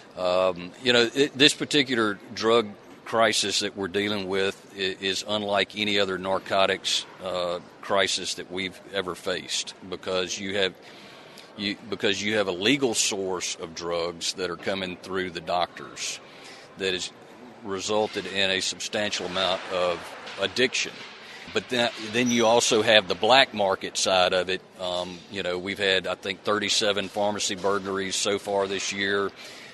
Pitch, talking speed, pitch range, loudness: 95 Hz, 155 wpm, 95-105 Hz, -25 LUFS